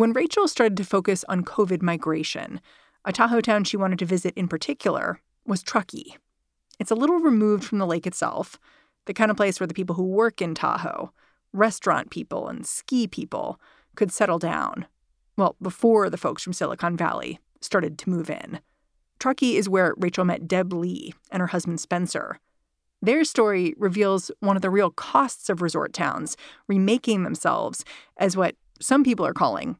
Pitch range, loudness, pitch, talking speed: 180-220 Hz, -24 LUFS, 195 Hz, 175 wpm